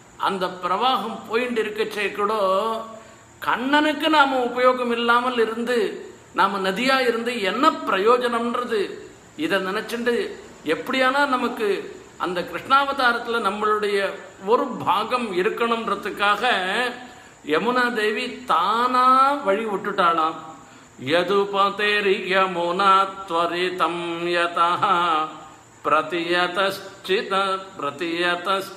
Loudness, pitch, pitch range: -21 LUFS, 215 Hz, 190-245 Hz